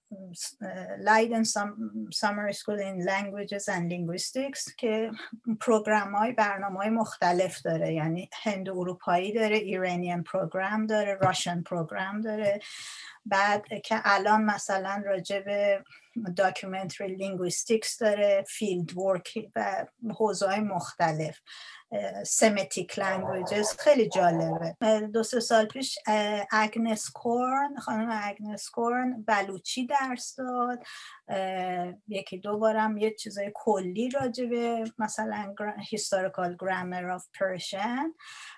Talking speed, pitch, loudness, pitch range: 105 wpm, 205 Hz, -29 LUFS, 190-225 Hz